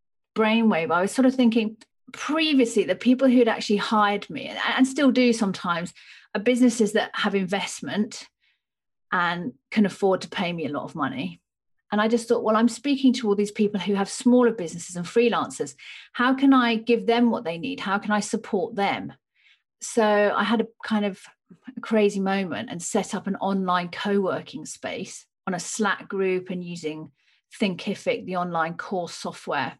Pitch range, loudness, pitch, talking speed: 195-235 Hz, -24 LUFS, 210 Hz, 175 wpm